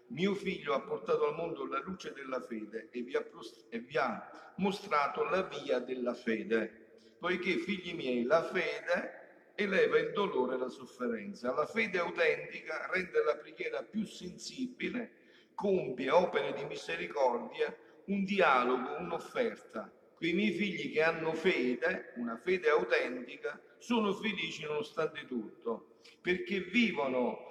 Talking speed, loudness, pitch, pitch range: 130 wpm, -34 LUFS, 190 Hz, 150-240 Hz